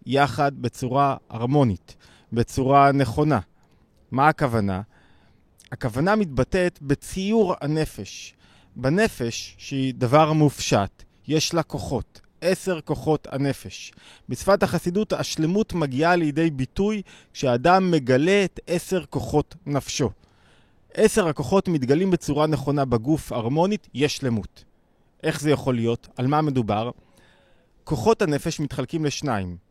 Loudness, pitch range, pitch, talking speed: -23 LUFS, 120-160 Hz, 140 Hz, 105 wpm